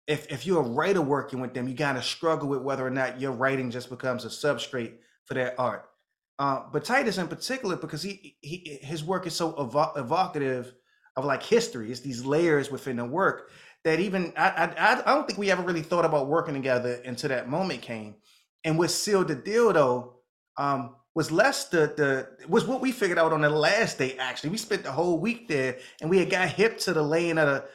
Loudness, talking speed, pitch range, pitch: -27 LUFS, 220 wpm, 130-175 Hz, 150 Hz